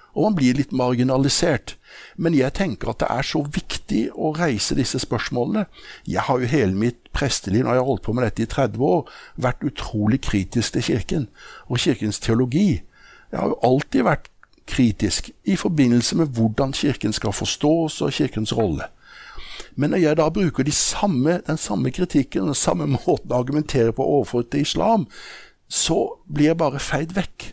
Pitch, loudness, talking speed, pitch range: 130 Hz, -21 LUFS, 180 wpm, 115-155 Hz